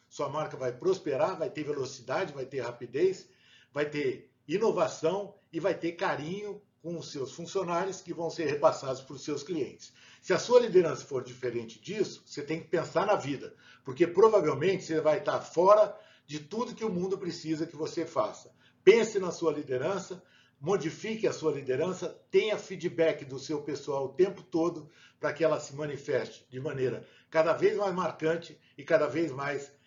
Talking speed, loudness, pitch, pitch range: 175 wpm, -30 LUFS, 160 Hz, 150-195 Hz